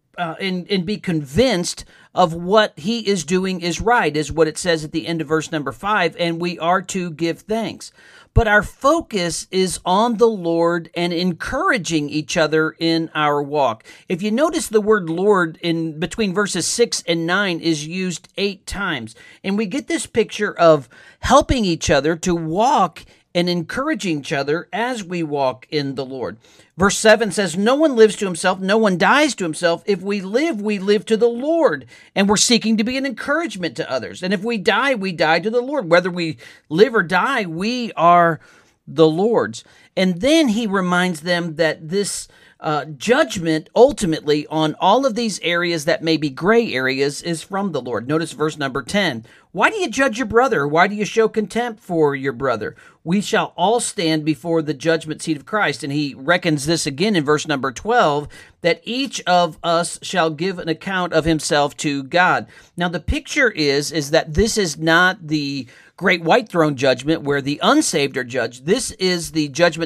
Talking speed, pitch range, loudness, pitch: 190 wpm, 160-215 Hz, -19 LUFS, 175 Hz